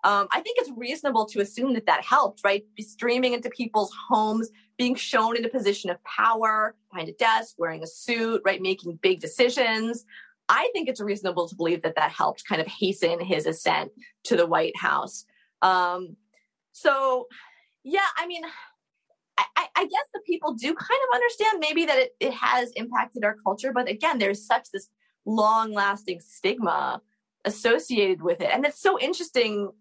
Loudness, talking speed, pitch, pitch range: -25 LUFS, 175 wpm, 225 Hz, 200-275 Hz